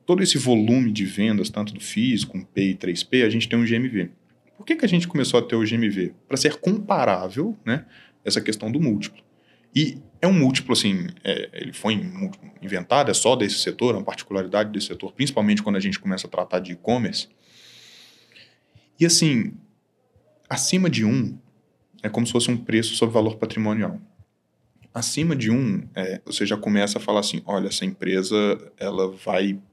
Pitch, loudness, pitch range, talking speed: 115 Hz, -22 LUFS, 105-165 Hz, 185 wpm